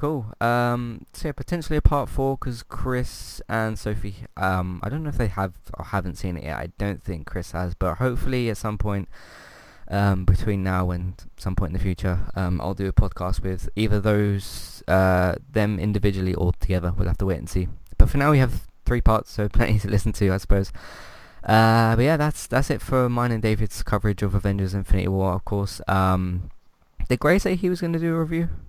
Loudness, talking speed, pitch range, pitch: -24 LUFS, 220 wpm, 95-120 Hz, 100 Hz